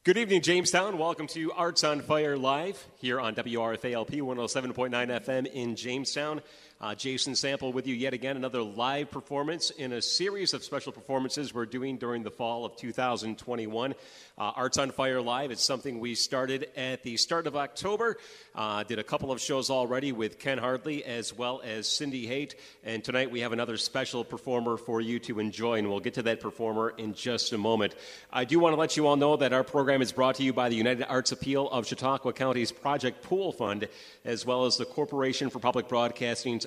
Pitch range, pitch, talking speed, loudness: 120-140 Hz, 130 Hz, 200 wpm, -30 LUFS